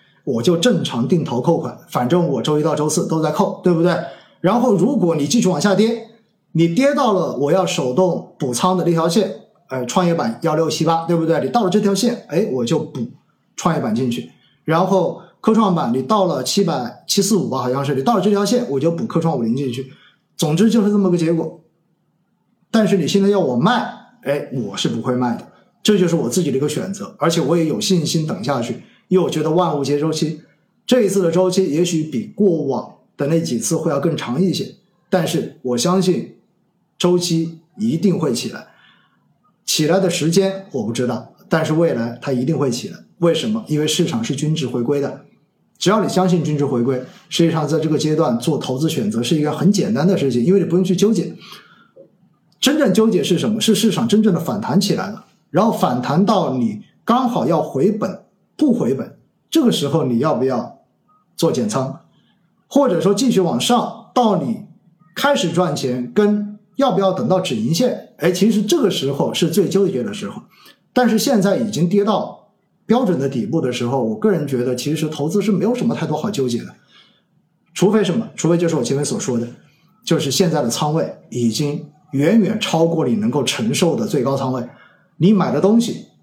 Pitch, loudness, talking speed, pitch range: 180 Hz, -18 LUFS, 290 characters per minute, 155-205 Hz